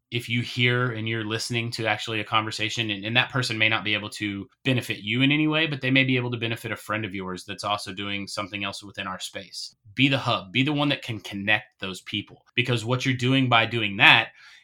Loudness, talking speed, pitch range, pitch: -24 LUFS, 250 wpm, 105-125 Hz, 110 Hz